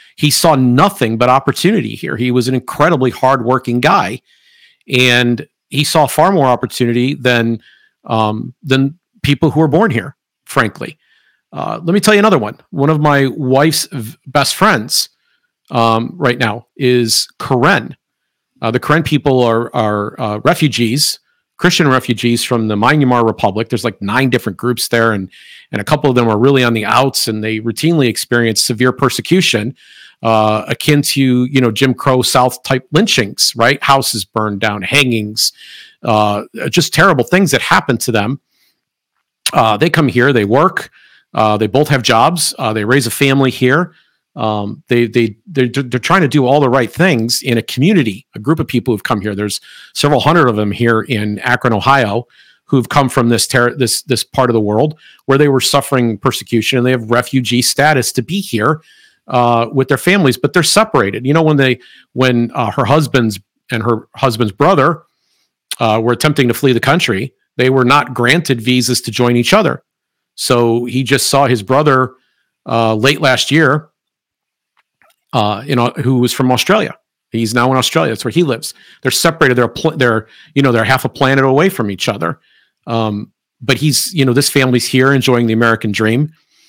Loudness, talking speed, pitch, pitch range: -13 LUFS, 185 wpm, 125 Hz, 115-140 Hz